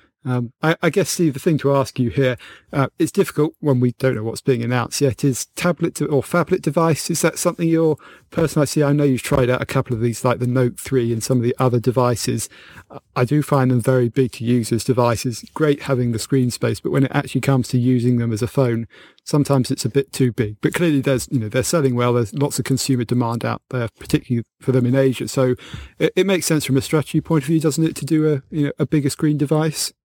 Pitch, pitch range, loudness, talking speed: 135 Hz, 125-150 Hz, -19 LUFS, 255 wpm